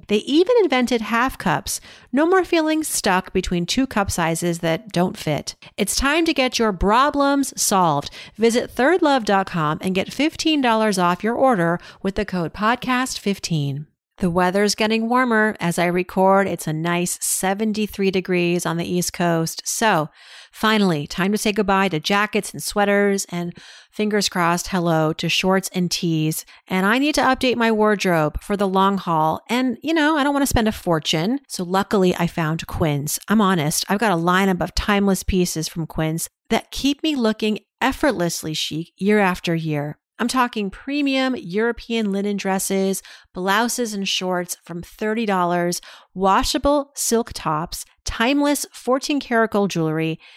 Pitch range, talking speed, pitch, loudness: 175-235 Hz, 160 wpm, 195 Hz, -20 LUFS